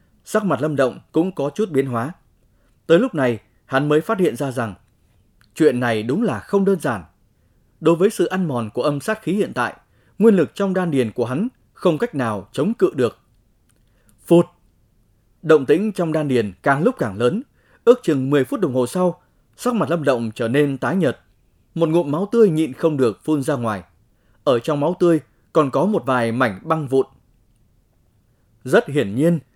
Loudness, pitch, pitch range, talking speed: -20 LUFS, 135 Hz, 115-165 Hz, 200 wpm